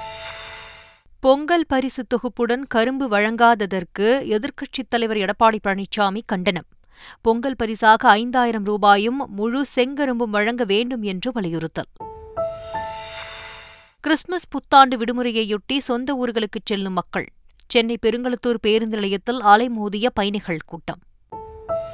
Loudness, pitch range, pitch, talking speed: -20 LUFS, 210-260 Hz, 230 Hz, 95 wpm